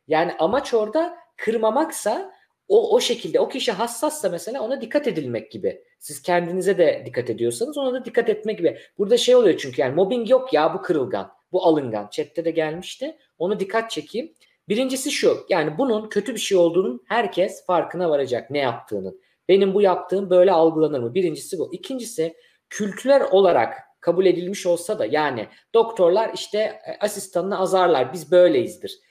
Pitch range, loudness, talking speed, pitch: 175-275 Hz, -21 LUFS, 160 wpm, 210 Hz